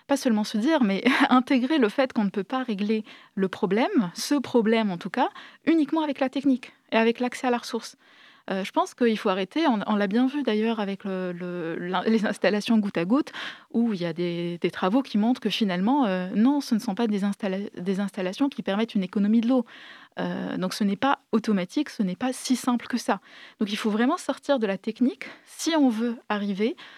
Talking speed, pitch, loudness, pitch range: 225 wpm, 230 Hz, -25 LUFS, 205-270 Hz